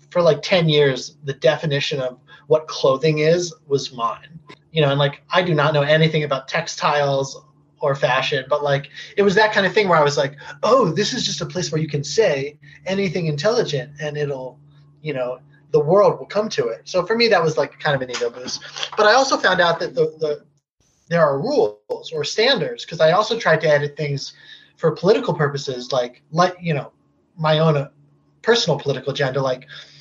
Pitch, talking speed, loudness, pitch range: 150 Hz, 205 wpm, -19 LUFS, 145-180 Hz